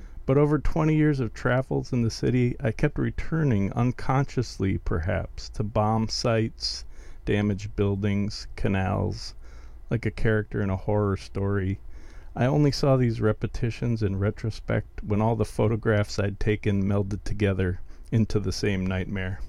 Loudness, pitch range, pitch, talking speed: -26 LUFS, 95-115 Hz, 105 Hz, 140 wpm